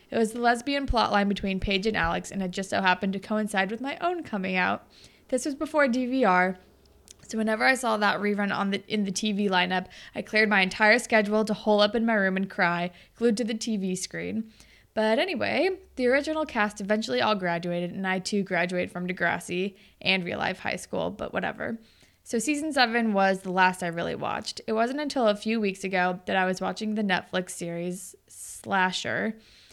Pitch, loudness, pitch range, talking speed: 205 Hz, -26 LUFS, 185-230 Hz, 200 wpm